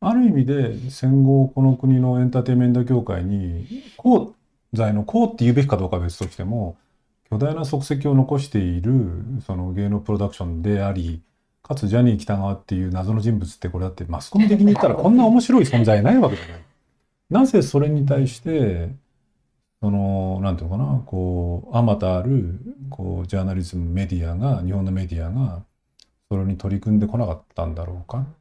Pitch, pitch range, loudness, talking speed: 110 Hz, 95-135 Hz, -20 LUFS, 385 characters per minute